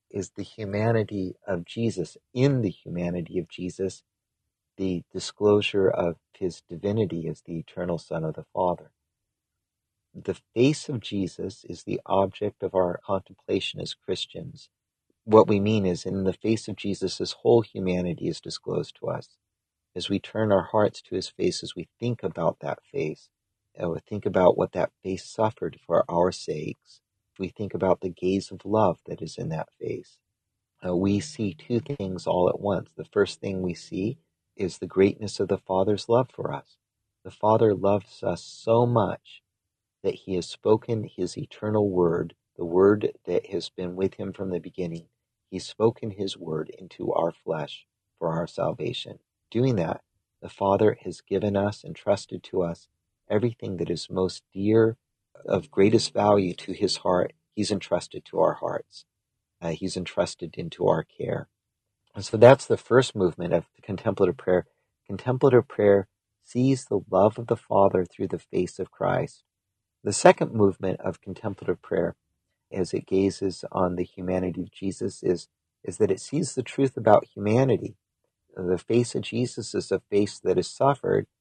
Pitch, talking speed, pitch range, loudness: 100 Hz, 170 wpm, 90-110 Hz, -26 LUFS